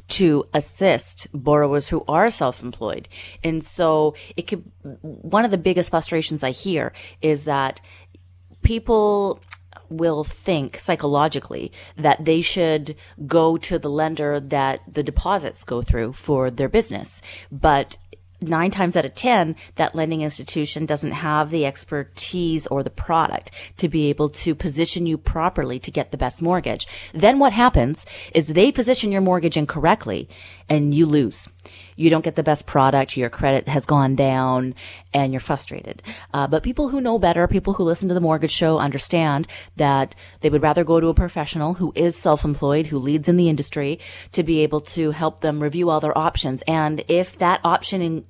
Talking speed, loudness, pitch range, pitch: 170 wpm, -21 LUFS, 135-170 Hz, 155 Hz